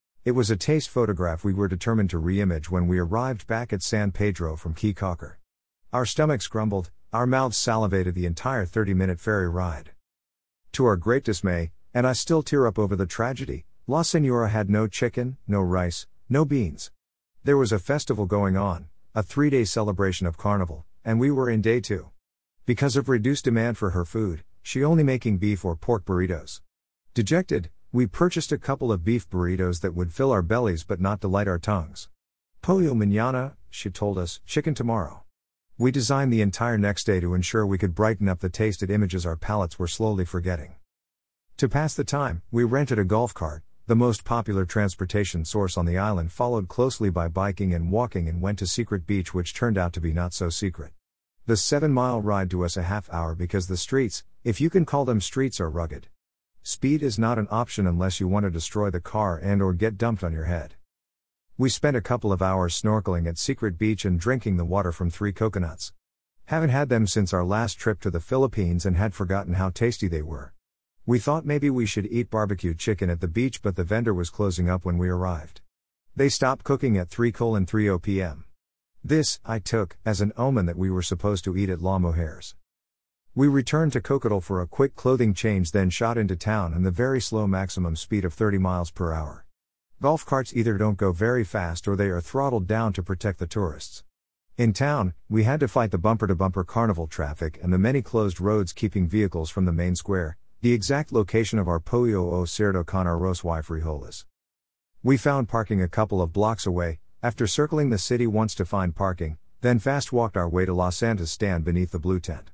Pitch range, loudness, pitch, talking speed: 90-115 Hz, -25 LUFS, 100 Hz, 205 wpm